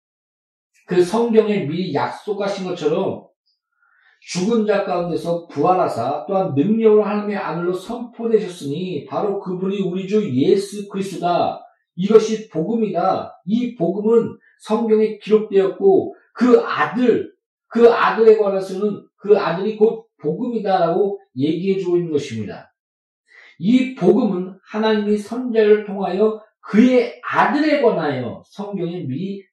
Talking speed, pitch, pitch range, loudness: 275 characters per minute, 205 Hz, 185-225 Hz, -19 LUFS